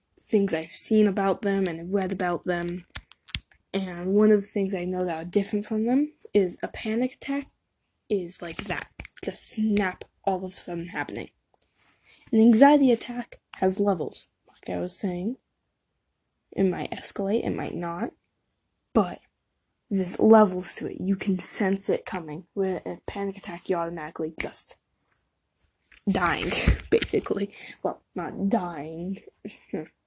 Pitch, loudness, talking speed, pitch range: 190 Hz, -26 LUFS, 145 wpm, 175-210 Hz